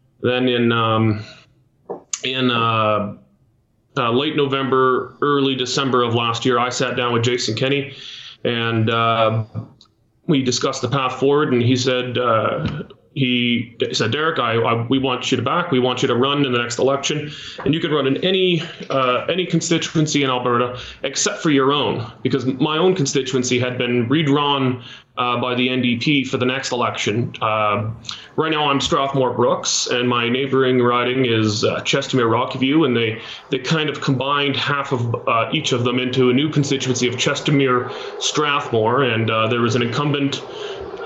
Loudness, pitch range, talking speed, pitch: -19 LUFS, 120-140 Hz, 170 wpm, 130 Hz